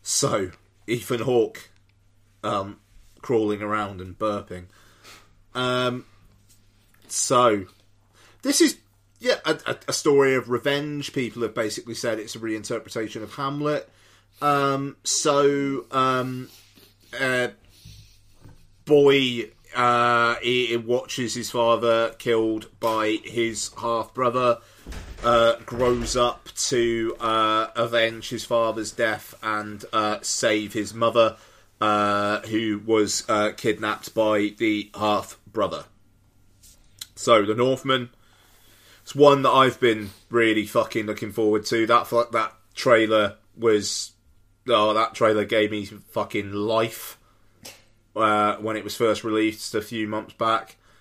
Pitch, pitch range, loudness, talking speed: 110 Hz, 105-120 Hz, -23 LUFS, 115 wpm